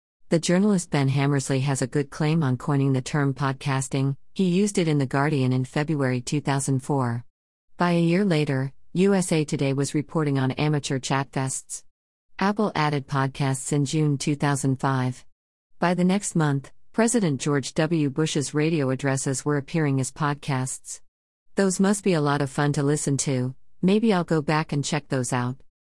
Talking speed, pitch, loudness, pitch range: 165 wpm, 145 Hz, -24 LUFS, 135-160 Hz